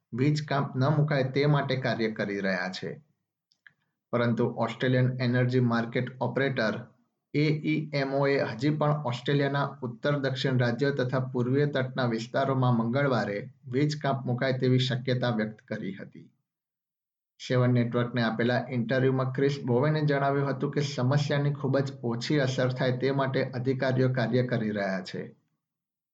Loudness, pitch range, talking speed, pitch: -28 LUFS, 120-140 Hz, 125 wpm, 130 Hz